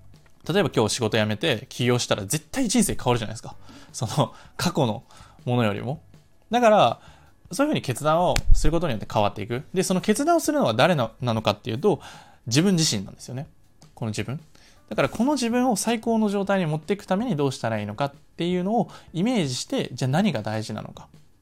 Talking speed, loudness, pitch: 425 characters per minute, -24 LUFS, 145 Hz